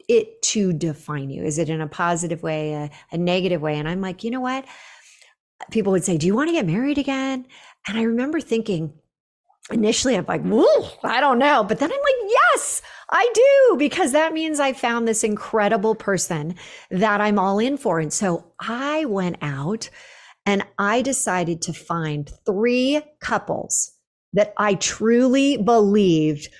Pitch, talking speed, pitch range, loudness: 220 Hz, 170 wpm, 175-270 Hz, -21 LUFS